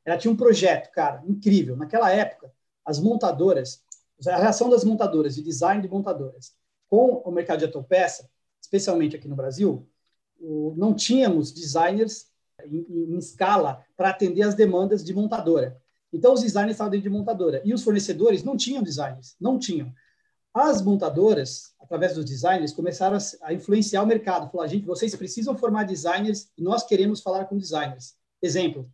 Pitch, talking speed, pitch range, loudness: 185 Hz, 165 wpm, 160-215 Hz, -23 LUFS